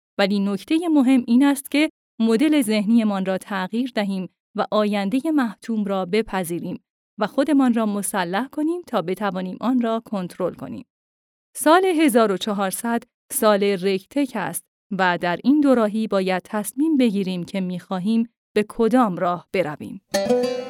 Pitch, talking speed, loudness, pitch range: 215 Hz, 135 wpm, -21 LUFS, 190-250 Hz